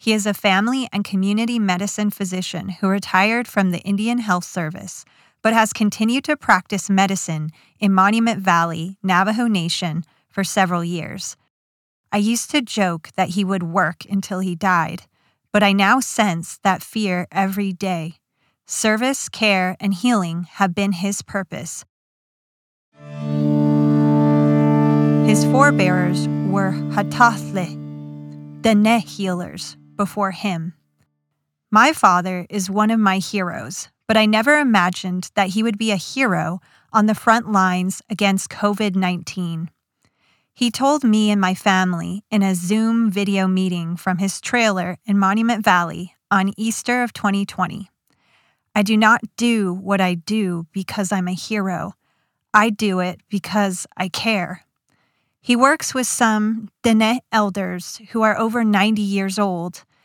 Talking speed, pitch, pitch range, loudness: 140 wpm, 195 Hz, 175-215 Hz, -19 LUFS